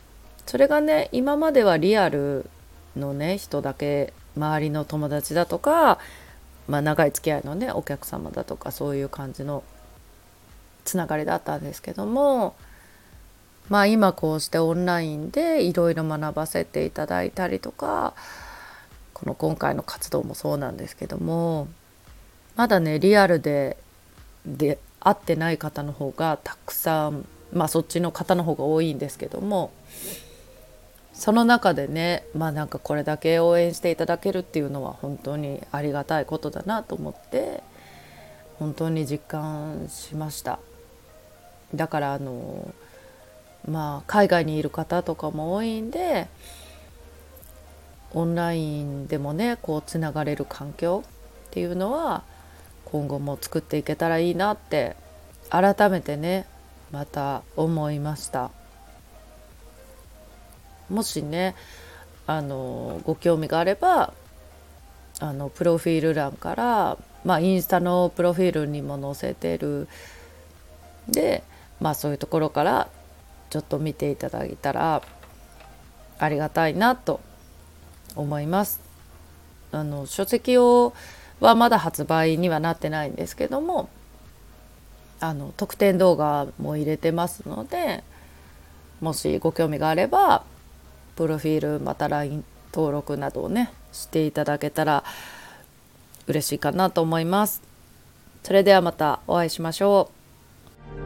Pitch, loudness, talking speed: 150 Hz, -24 LUFS, 260 characters per minute